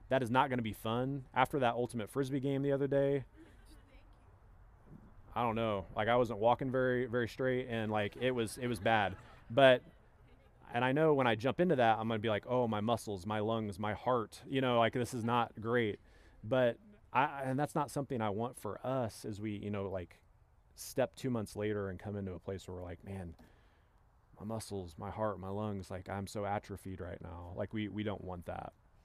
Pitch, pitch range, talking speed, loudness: 110 Hz, 100-125 Hz, 220 wpm, -35 LUFS